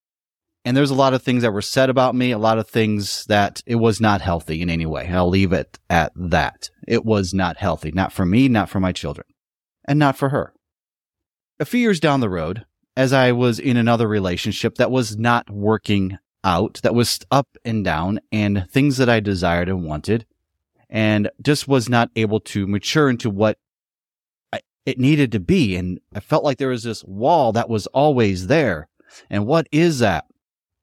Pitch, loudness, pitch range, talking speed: 110 Hz, -19 LUFS, 95-130 Hz, 195 wpm